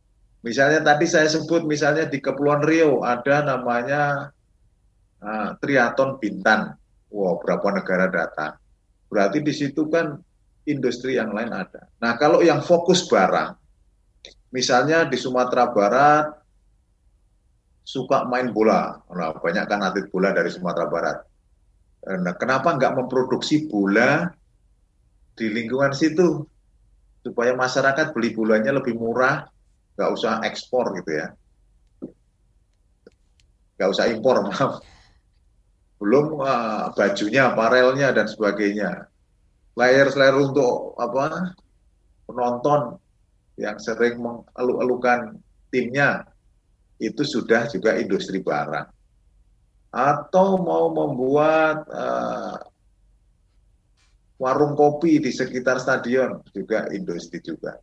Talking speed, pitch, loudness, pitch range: 105 wpm, 130 Hz, -21 LUFS, 115-150 Hz